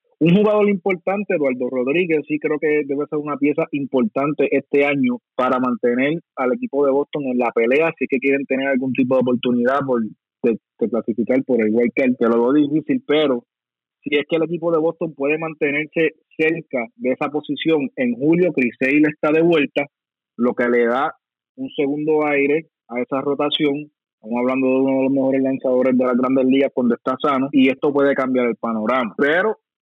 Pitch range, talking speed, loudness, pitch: 130-155 Hz, 195 wpm, -19 LUFS, 140 Hz